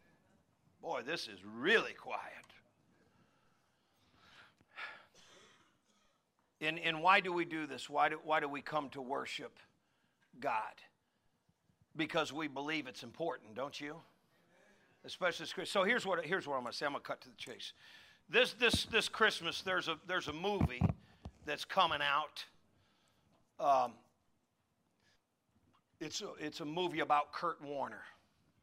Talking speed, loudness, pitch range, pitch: 140 wpm, -36 LUFS, 140-170 Hz, 155 Hz